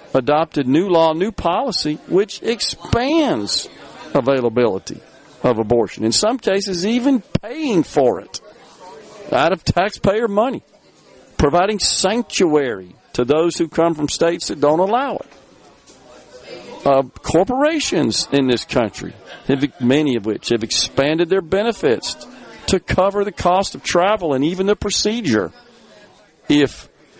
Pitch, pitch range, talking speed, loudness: 170 Hz, 135-205 Hz, 125 wpm, -18 LUFS